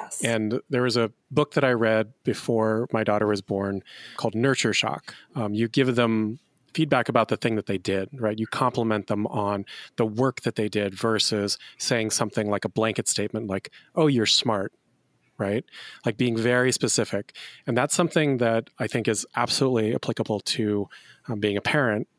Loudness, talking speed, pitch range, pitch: -25 LUFS, 180 wpm, 105-125 Hz, 115 Hz